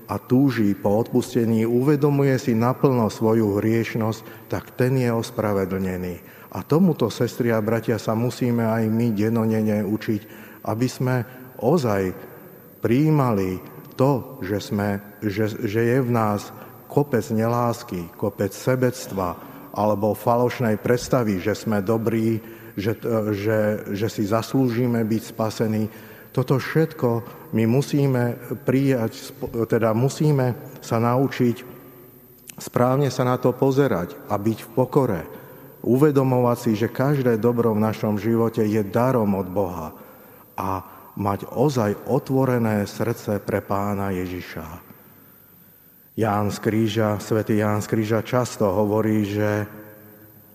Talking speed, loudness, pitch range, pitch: 120 wpm, -22 LUFS, 105-125 Hz, 115 Hz